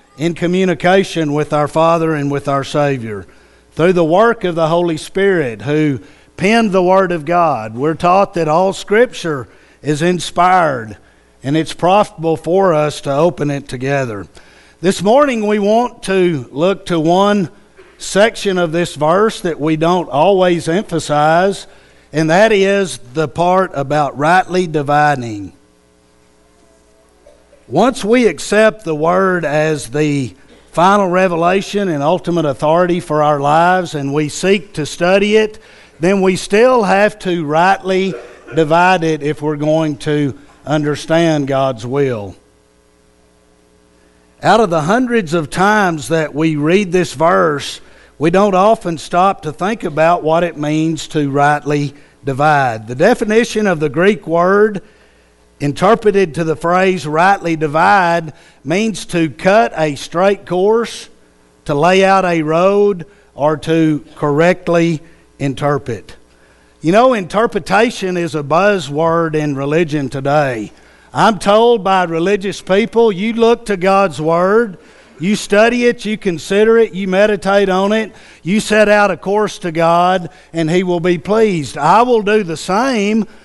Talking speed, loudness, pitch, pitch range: 140 wpm, -14 LUFS, 170 Hz, 150-195 Hz